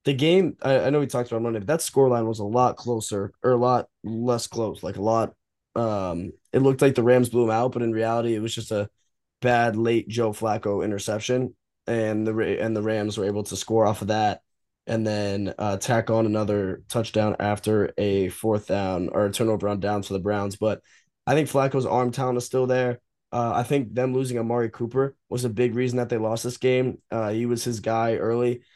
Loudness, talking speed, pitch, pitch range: -24 LUFS, 225 wpm, 115 Hz, 105-125 Hz